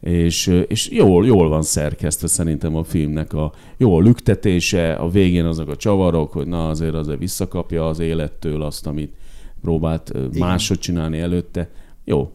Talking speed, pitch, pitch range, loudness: 150 wpm, 80 Hz, 80-90 Hz, -18 LUFS